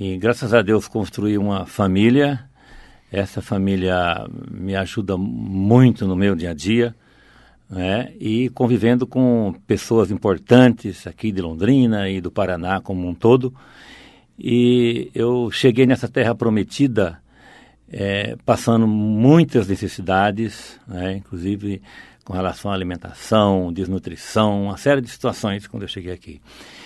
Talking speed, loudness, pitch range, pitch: 125 wpm, -19 LUFS, 95-120 Hz, 105 Hz